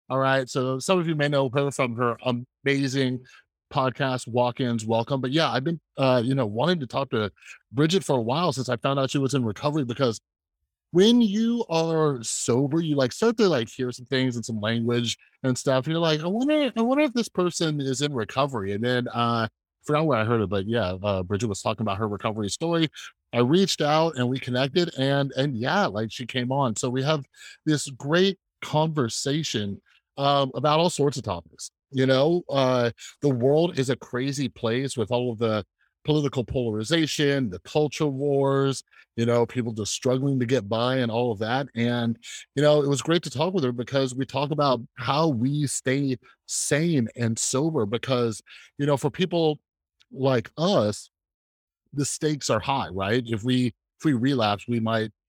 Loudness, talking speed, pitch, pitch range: -25 LUFS, 200 wpm, 130 Hz, 120-150 Hz